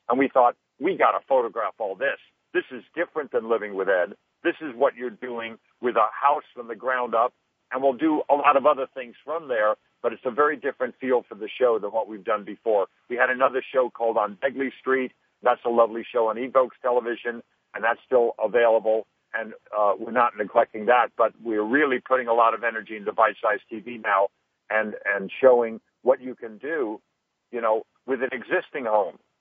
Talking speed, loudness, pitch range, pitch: 205 wpm, -24 LUFS, 115-135 Hz, 125 Hz